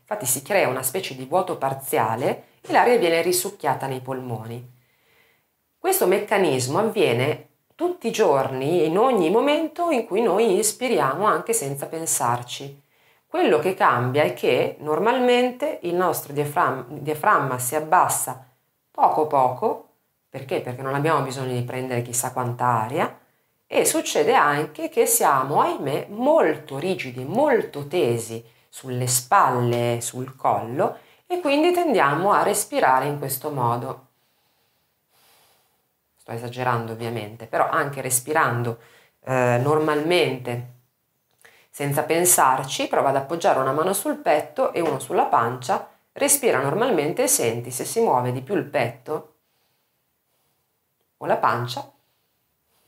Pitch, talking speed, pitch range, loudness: 145 Hz, 125 wpm, 125-180 Hz, -22 LUFS